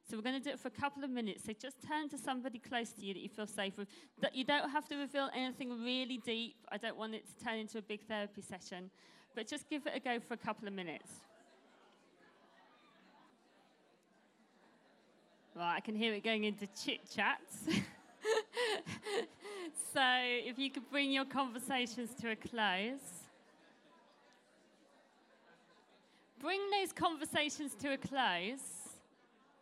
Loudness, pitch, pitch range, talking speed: -39 LUFS, 250 Hz, 220-280 Hz, 165 wpm